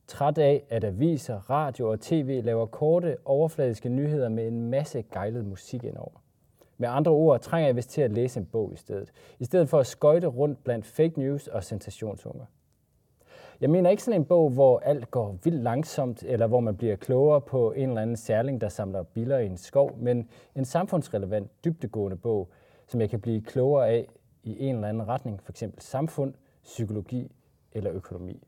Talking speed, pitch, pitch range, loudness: 190 wpm, 125 Hz, 110-145 Hz, -27 LUFS